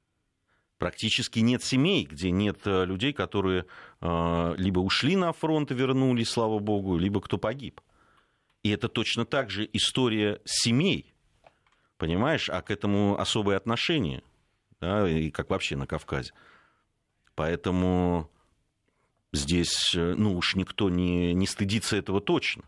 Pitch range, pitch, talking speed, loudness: 90-115 Hz, 100 Hz, 125 wpm, -27 LUFS